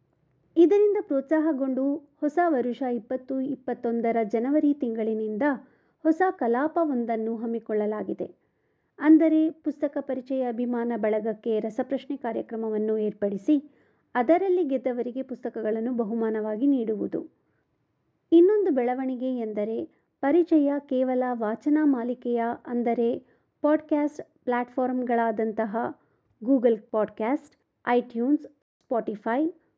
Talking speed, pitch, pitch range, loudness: 75 wpm, 255 Hz, 230-295 Hz, -26 LUFS